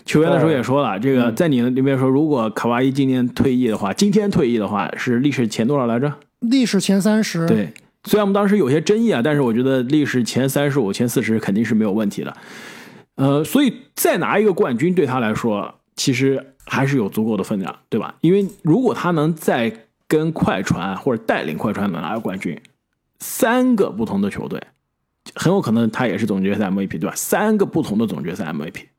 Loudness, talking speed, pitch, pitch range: -19 LUFS, 325 characters per minute, 145 Hz, 125-205 Hz